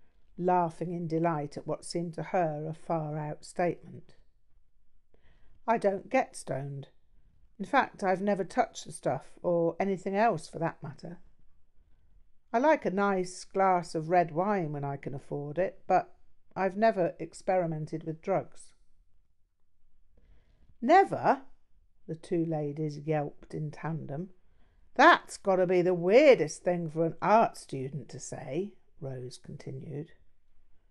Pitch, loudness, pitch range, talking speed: 165 Hz, -29 LUFS, 140-185 Hz, 135 wpm